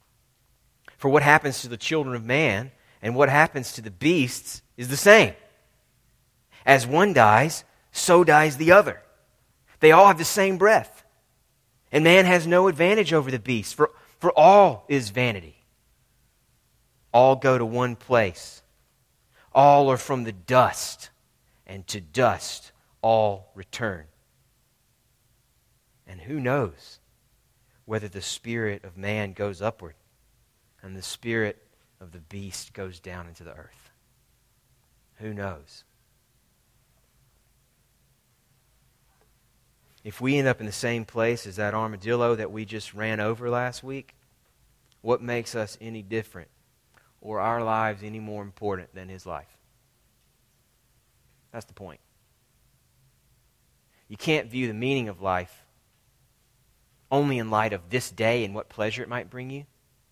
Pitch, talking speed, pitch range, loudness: 120 Hz, 135 wpm, 105-130 Hz, -22 LUFS